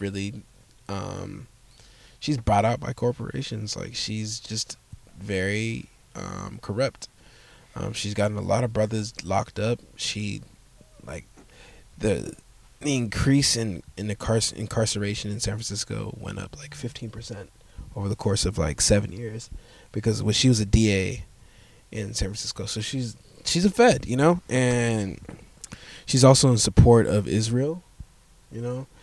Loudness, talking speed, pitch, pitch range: -25 LUFS, 150 wpm, 110 Hz, 100-120 Hz